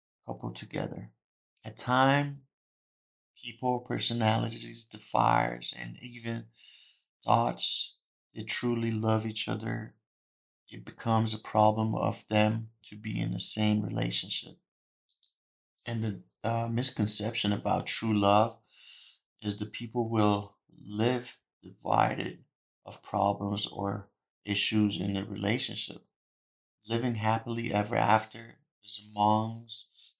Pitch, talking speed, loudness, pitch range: 110 Hz, 105 wpm, -28 LUFS, 105-115 Hz